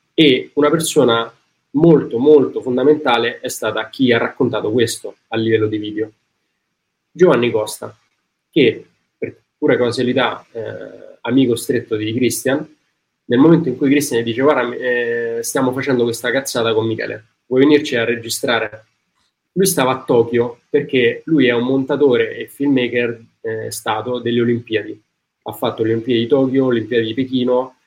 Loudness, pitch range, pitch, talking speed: -16 LUFS, 115-135 Hz, 120 Hz, 150 wpm